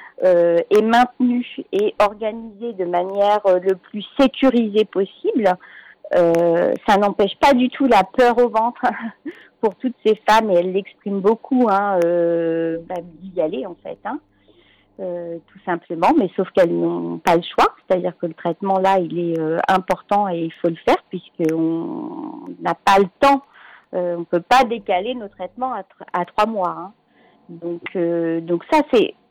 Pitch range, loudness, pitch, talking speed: 175-245 Hz, -19 LUFS, 195 Hz, 175 wpm